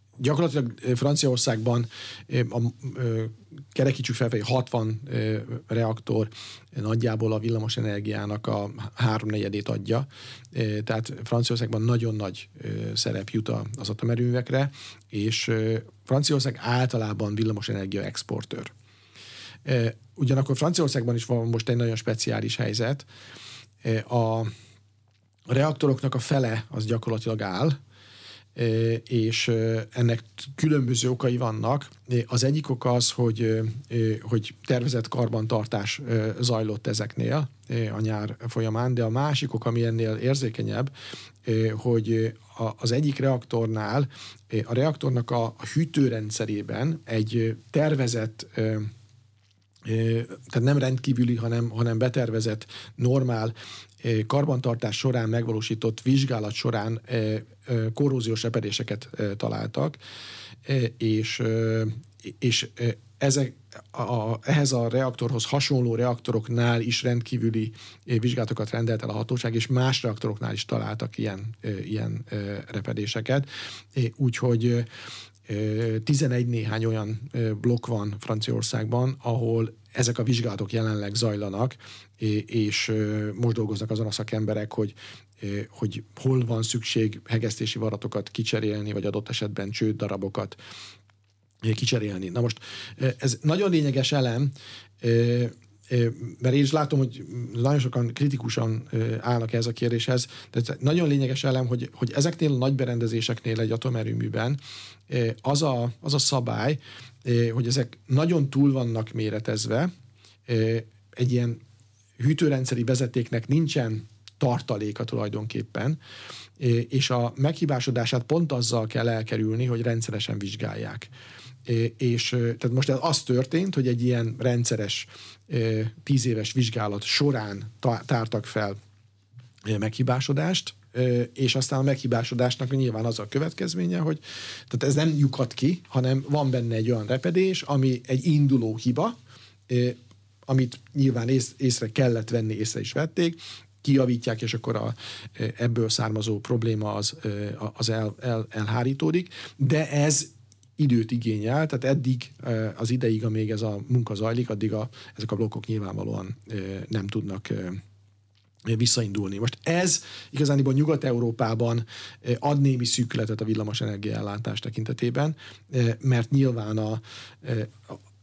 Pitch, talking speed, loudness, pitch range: 115 Hz, 110 wpm, -26 LUFS, 110-130 Hz